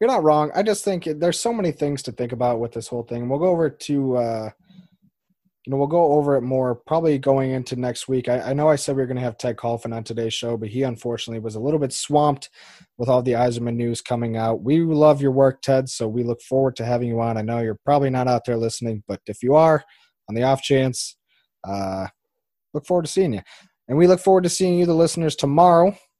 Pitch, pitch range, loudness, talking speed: 135 Hz, 120-155 Hz, -21 LUFS, 250 wpm